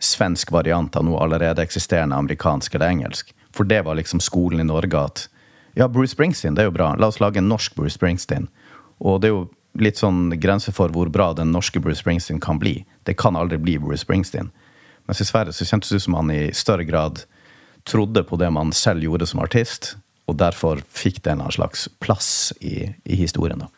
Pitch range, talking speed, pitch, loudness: 80-100 Hz, 210 wpm, 90 Hz, -20 LUFS